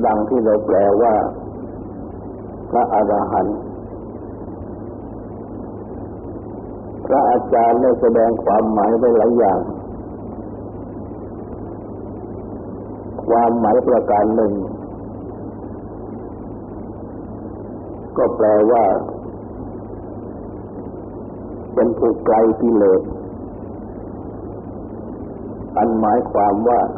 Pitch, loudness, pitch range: 105 Hz, -16 LUFS, 100-115 Hz